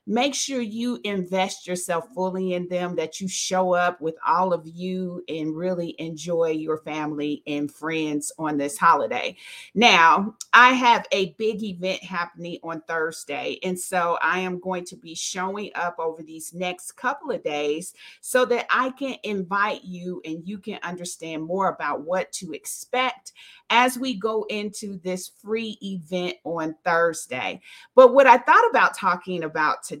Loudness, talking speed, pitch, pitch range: -23 LUFS, 165 wpm, 180 Hz, 165-205 Hz